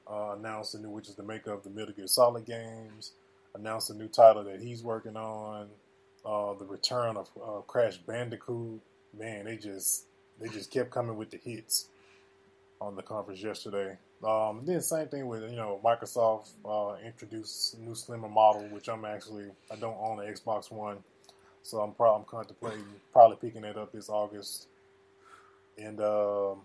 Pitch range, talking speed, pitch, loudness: 100-110 Hz, 180 wpm, 105 Hz, -29 LUFS